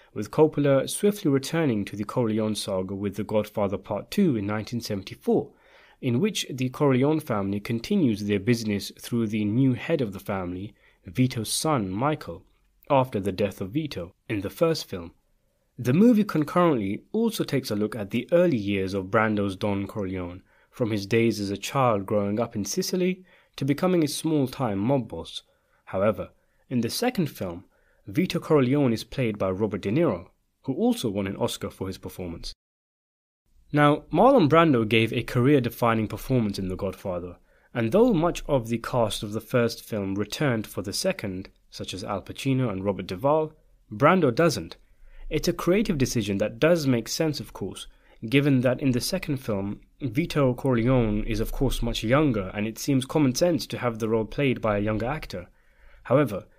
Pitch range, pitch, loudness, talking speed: 105-145 Hz, 120 Hz, -25 LUFS, 175 wpm